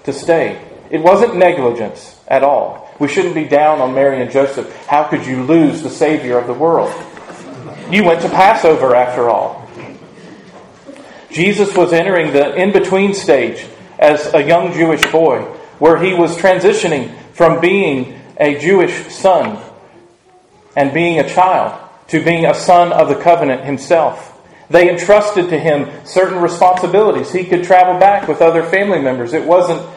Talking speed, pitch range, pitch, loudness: 160 wpm, 145-185 Hz, 170 Hz, -12 LUFS